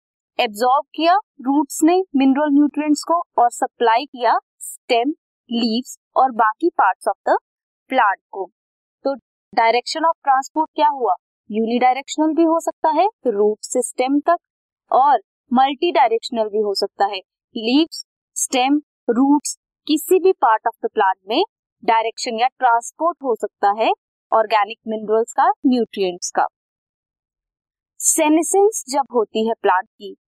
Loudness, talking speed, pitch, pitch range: -19 LUFS, 135 wpm, 270 Hz, 230-330 Hz